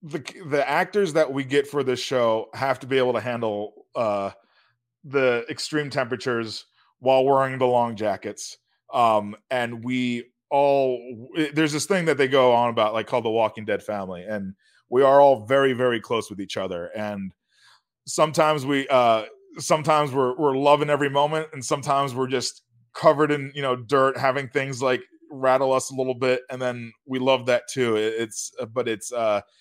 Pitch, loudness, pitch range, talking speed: 130 Hz, -23 LUFS, 120-145 Hz, 185 wpm